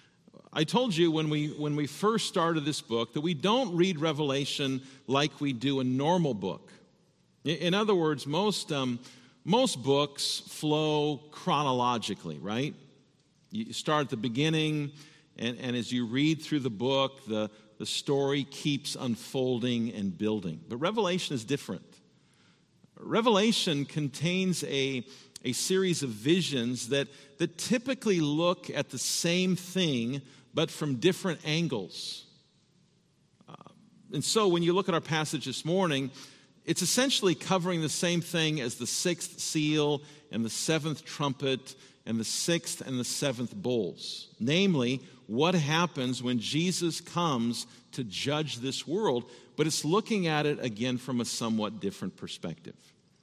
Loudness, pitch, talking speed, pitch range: -30 LUFS, 150 Hz, 145 wpm, 130-170 Hz